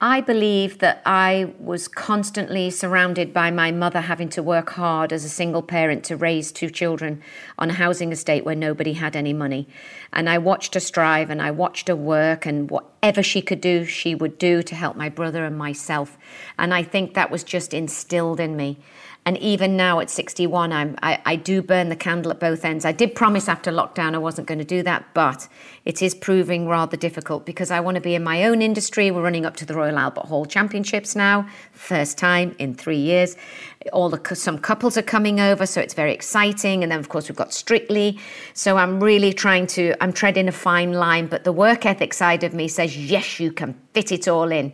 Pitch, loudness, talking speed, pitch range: 175 Hz, -21 LUFS, 220 wpm, 160-190 Hz